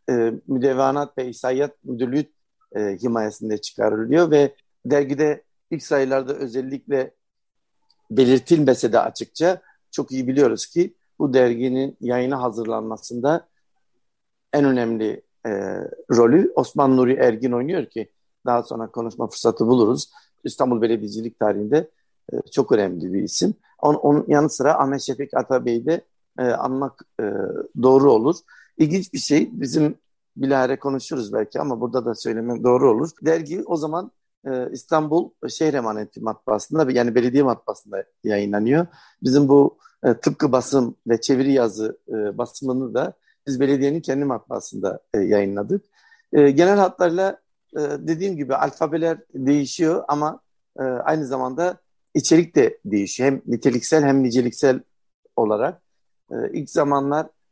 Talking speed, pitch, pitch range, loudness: 125 wpm, 135 Hz, 125-155 Hz, -21 LUFS